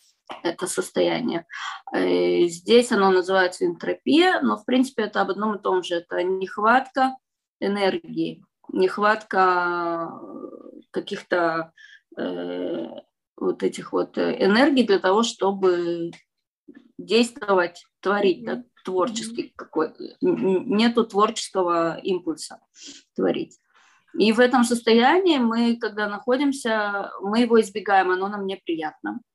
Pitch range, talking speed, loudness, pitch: 180-235 Hz, 100 wpm, -22 LUFS, 200 Hz